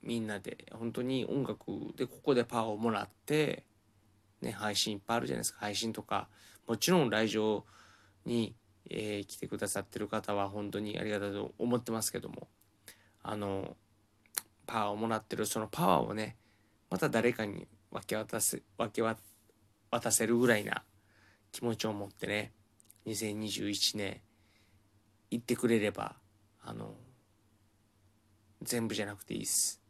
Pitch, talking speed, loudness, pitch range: 105 Hz, 285 characters per minute, -34 LUFS, 105-115 Hz